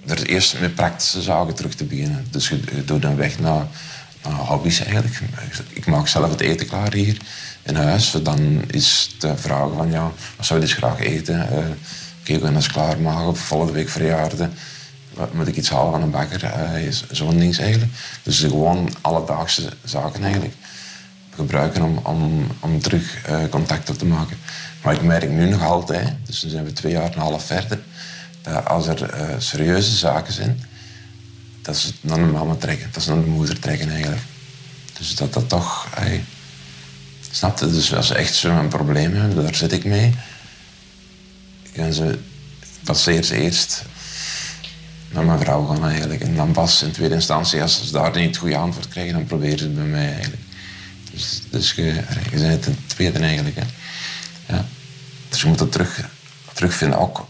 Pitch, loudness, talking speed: 105 Hz, -20 LUFS, 185 wpm